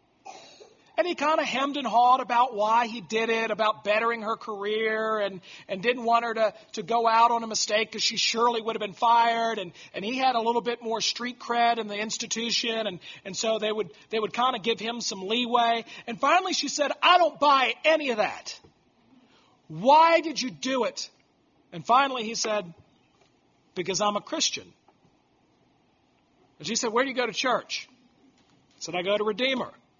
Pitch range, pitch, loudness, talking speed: 215-250 Hz, 230 Hz, -25 LUFS, 200 wpm